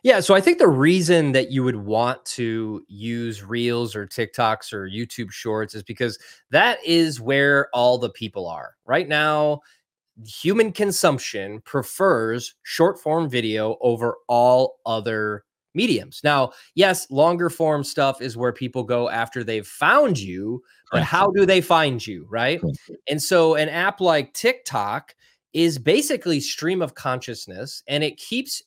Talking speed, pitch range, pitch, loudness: 155 wpm, 115-165 Hz, 130 Hz, -21 LUFS